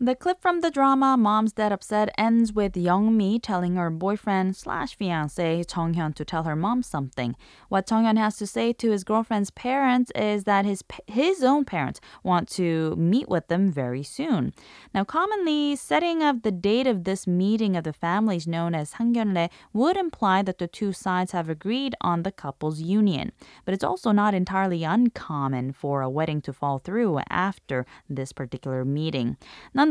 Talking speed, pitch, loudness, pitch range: 180 wpm, 195 Hz, -25 LUFS, 165-225 Hz